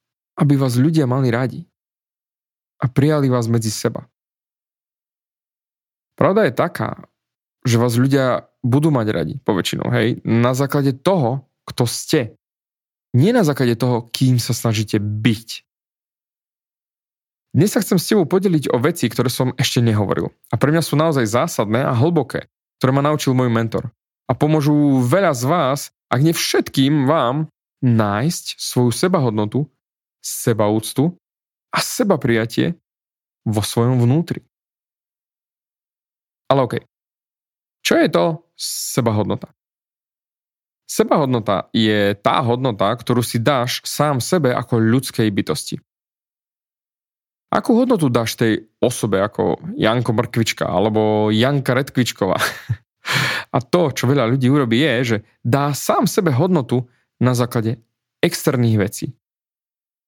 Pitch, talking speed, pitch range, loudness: 125 Hz, 125 wpm, 115-145 Hz, -18 LUFS